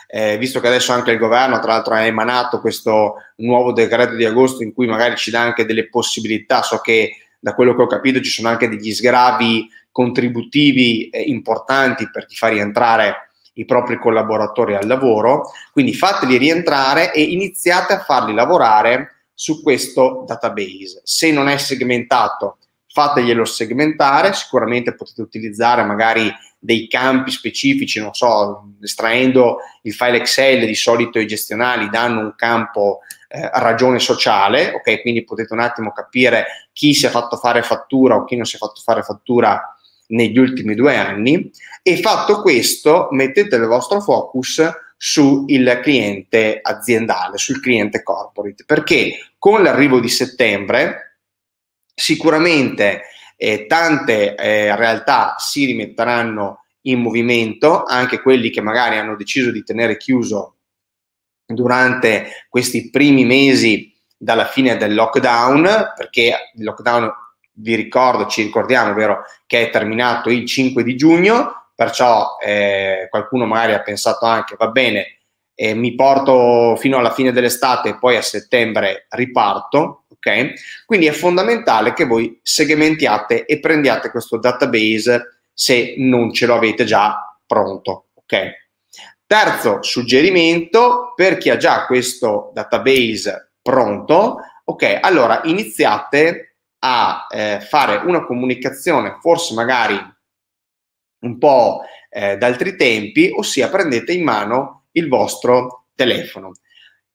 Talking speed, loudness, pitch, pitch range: 135 wpm, -15 LUFS, 120 Hz, 110-135 Hz